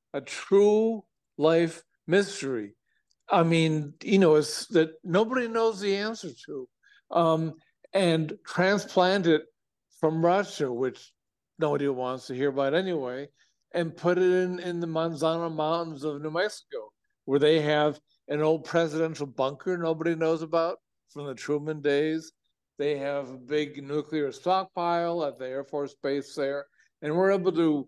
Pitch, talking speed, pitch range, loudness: 160 Hz, 150 wpm, 145-180 Hz, -27 LUFS